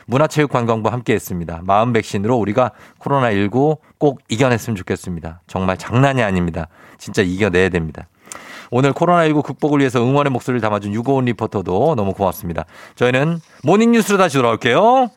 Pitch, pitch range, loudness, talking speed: 120 Hz, 95-140 Hz, -17 LUFS, 410 characters per minute